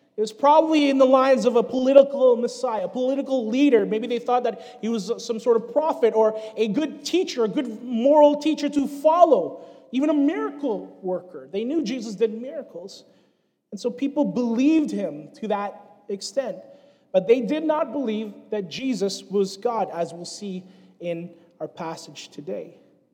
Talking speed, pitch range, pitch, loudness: 170 wpm, 215-280 Hz, 240 Hz, -22 LUFS